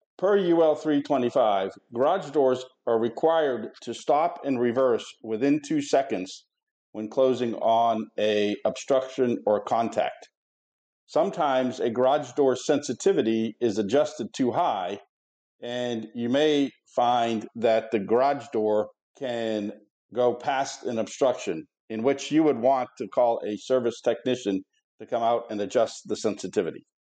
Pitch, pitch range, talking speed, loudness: 120 Hz, 110-140 Hz, 130 wpm, -25 LUFS